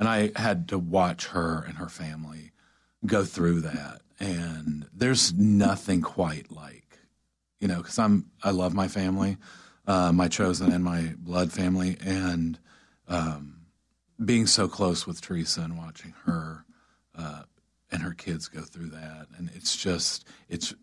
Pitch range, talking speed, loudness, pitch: 80-95 Hz, 155 wpm, -27 LUFS, 85 Hz